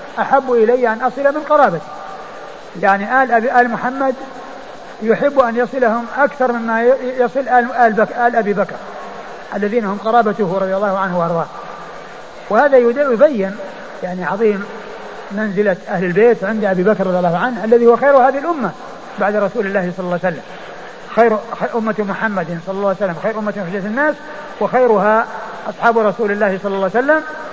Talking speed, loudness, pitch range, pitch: 160 wpm, -15 LUFS, 200-250 Hz, 225 Hz